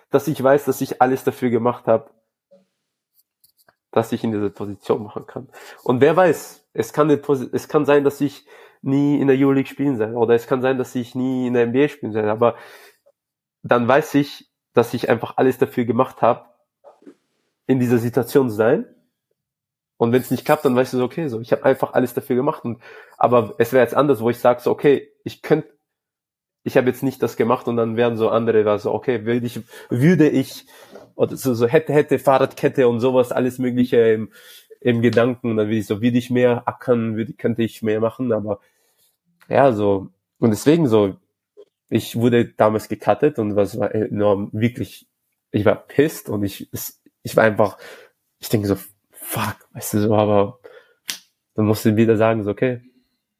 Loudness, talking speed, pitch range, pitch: -19 LUFS, 195 wpm, 110-135 Hz, 125 Hz